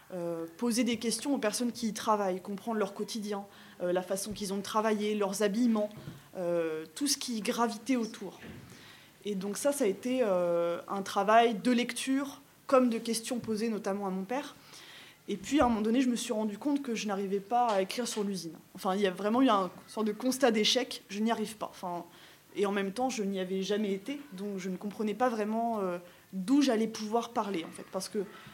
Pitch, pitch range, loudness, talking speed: 210 Hz, 195-240 Hz, -31 LUFS, 220 wpm